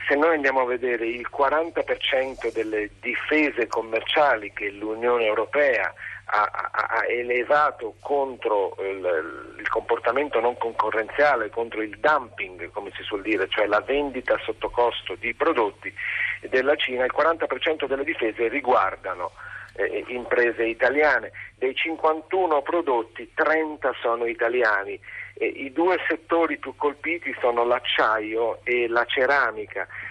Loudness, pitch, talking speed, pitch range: -24 LUFS, 140 Hz, 125 wpm, 120-175 Hz